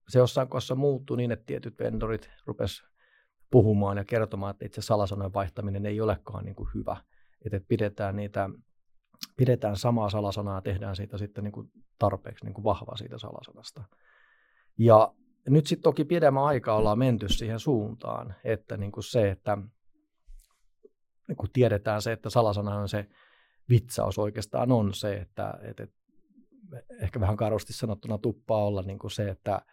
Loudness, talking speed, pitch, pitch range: -28 LUFS, 155 wpm, 110 Hz, 100-120 Hz